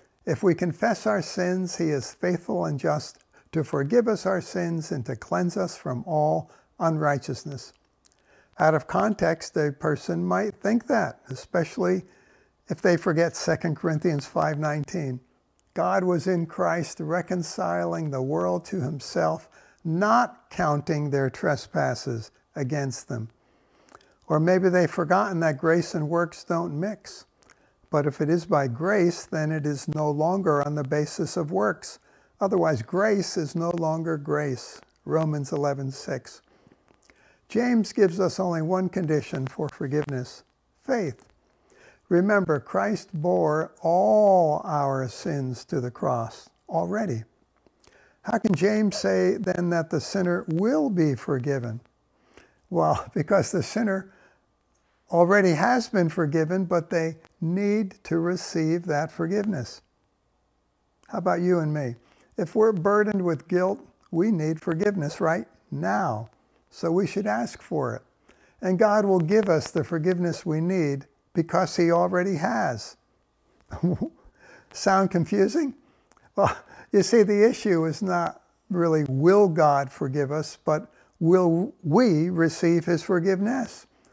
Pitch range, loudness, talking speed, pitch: 150-190 Hz, -25 LUFS, 135 wpm, 170 Hz